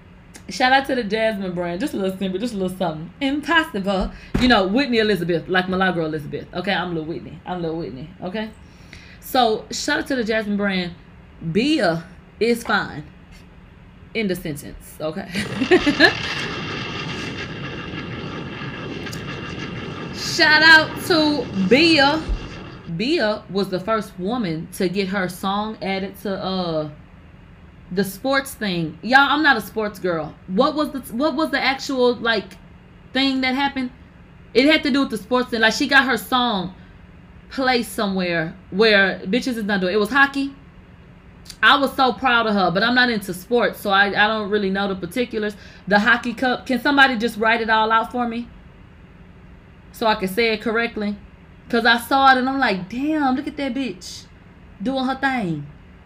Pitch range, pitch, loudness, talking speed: 185-260 Hz, 220 Hz, -20 LUFS, 165 wpm